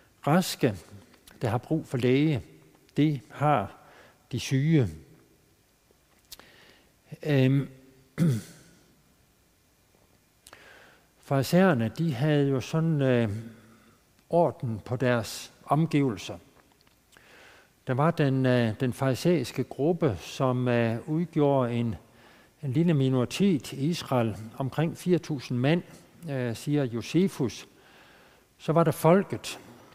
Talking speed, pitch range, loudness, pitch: 95 wpm, 120-155 Hz, -27 LUFS, 135 Hz